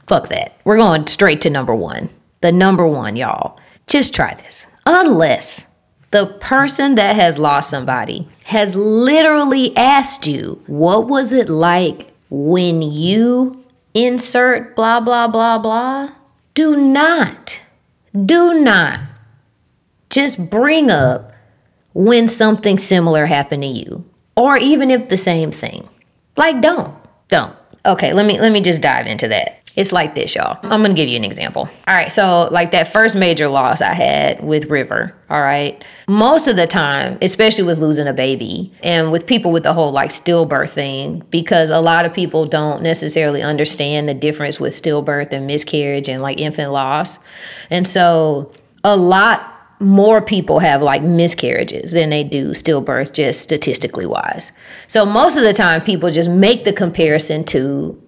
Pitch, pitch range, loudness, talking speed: 175 Hz, 150-225 Hz, -14 LUFS, 160 wpm